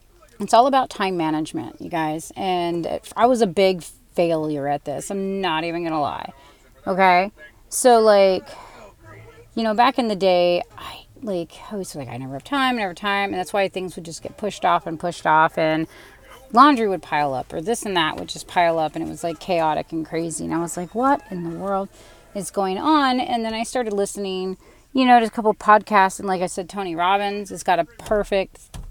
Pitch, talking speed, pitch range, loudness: 190 Hz, 220 wpm, 165-210 Hz, -21 LUFS